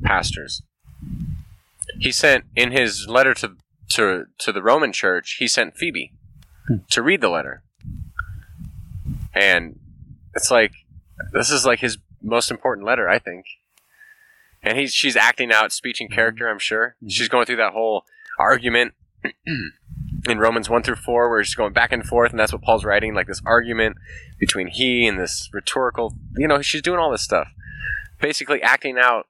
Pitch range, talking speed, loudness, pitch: 110-145 Hz, 165 wpm, -19 LUFS, 120 Hz